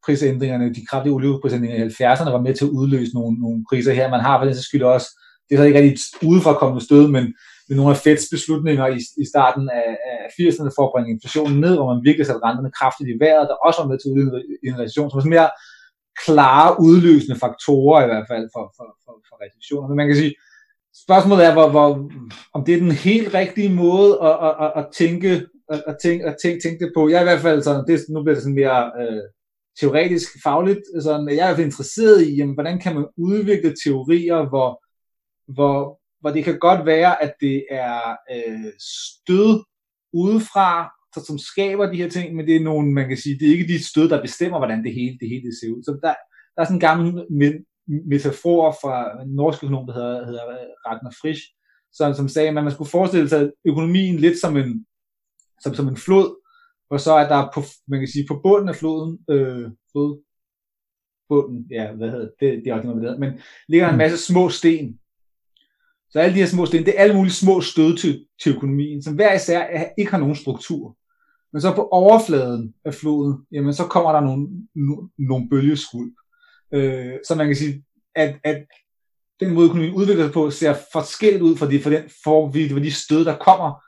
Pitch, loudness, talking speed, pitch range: 150 Hz, -18 LUFS, 210 wpm, 135-170 Hz